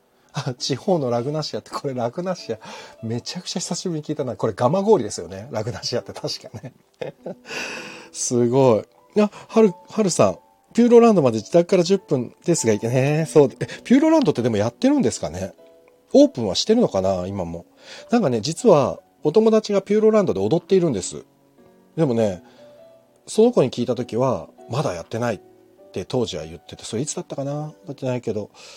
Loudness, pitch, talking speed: -21 LUFS, 145 Hz, 390 characters per minute